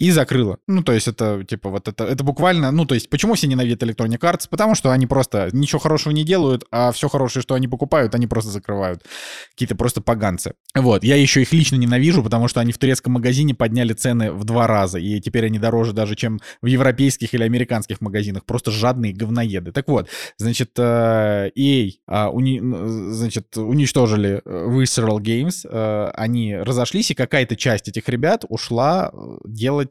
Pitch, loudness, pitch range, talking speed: 120 Hz, -19 LUFS, 110-135 Hz, 175 wpm